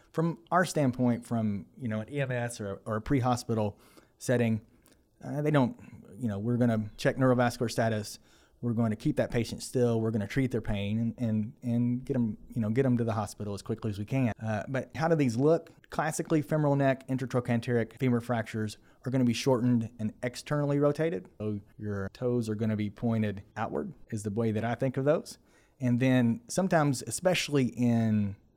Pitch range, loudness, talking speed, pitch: 110-135 Hz, -30 LUFS, 205 wpm, 120 Hz